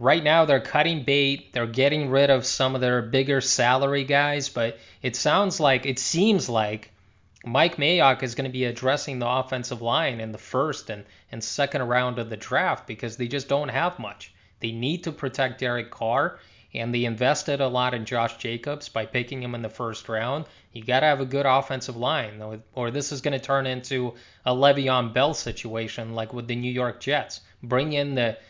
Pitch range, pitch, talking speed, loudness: 115-140 Hz, 130 Hz, 205 wpm, -24 LUFS